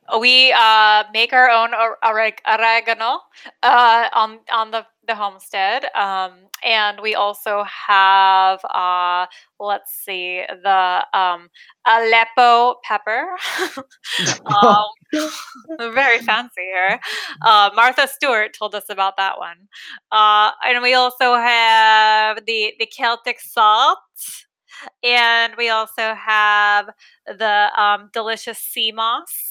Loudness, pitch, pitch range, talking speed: -16 LUFS, 225 Hz, 205-240 Hz, 110 wpm